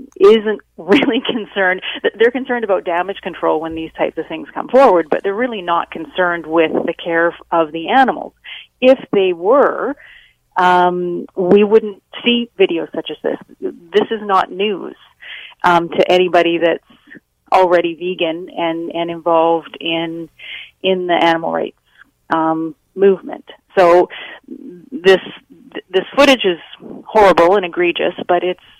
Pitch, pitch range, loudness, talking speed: 180 Hz, 170-225 Hz, -15 LUFS, 140 wpm